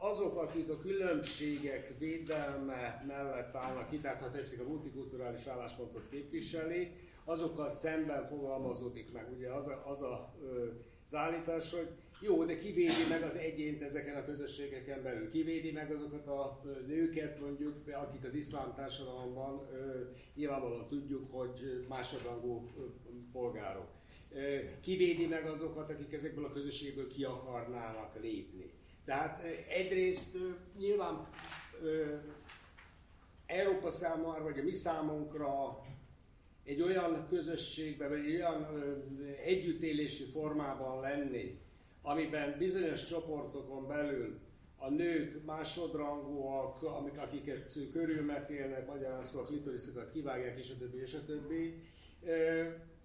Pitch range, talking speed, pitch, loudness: 135-160 Hz, 115 wpm, 145 Hz, -40 LUFS